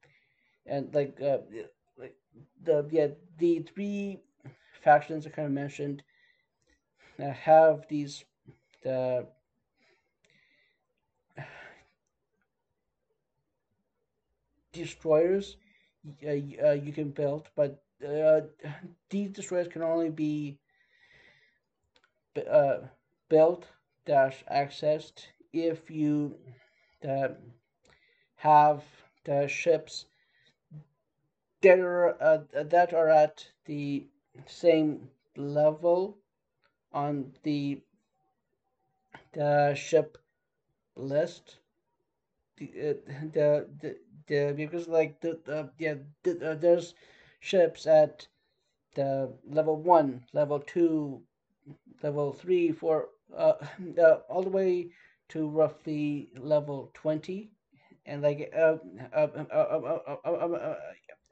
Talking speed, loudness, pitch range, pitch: 95 wpm, -28 LUFS, 145-170 Hz, 155 Hz